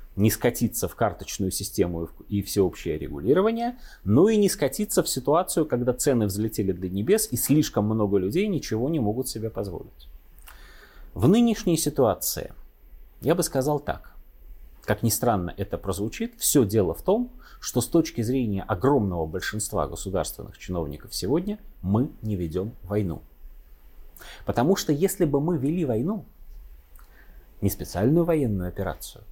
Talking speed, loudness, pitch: 140 wpm, -25 LUFS, 105 Hz